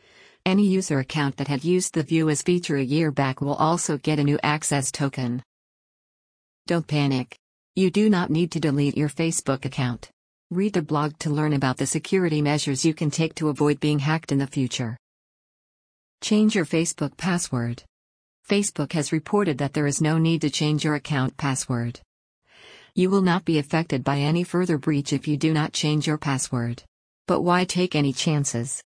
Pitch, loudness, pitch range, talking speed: 150 Hz, -23 LUFS, 140-165 Hz, 180 wpm